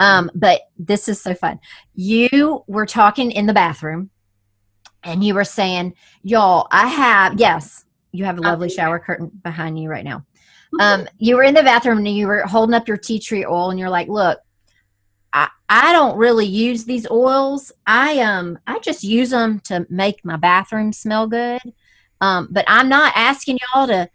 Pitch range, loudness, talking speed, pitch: 180-235 Hz, -16 LUFS, 190 wpm, 205 Hz